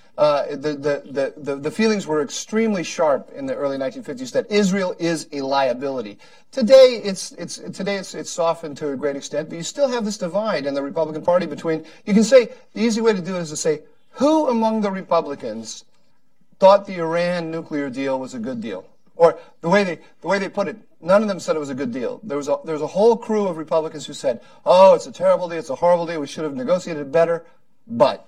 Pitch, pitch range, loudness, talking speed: 175 Hz, 150-215 Hz, -20 LUFS, 235 wpm